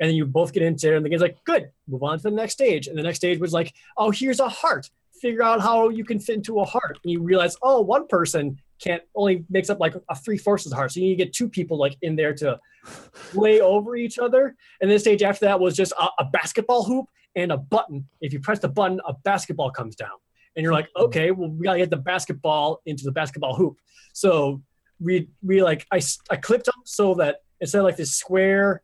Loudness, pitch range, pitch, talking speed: -22 LUFS, 160-215 Hz, 185 Hz, 250 wpm